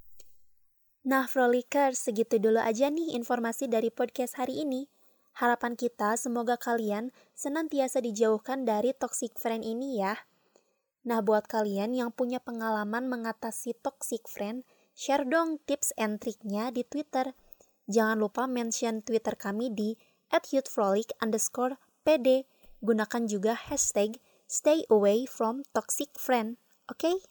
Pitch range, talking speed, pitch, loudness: 225-270 Hz, 115 wpm, 245 Hz, -30 LUFS